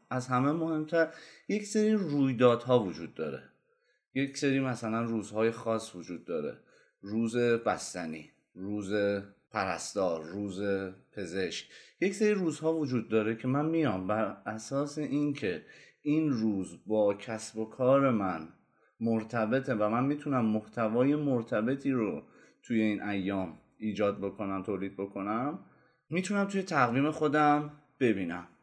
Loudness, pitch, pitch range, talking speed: -31 LUFS, 115 Hz, 105-145 Hz, 120 wpm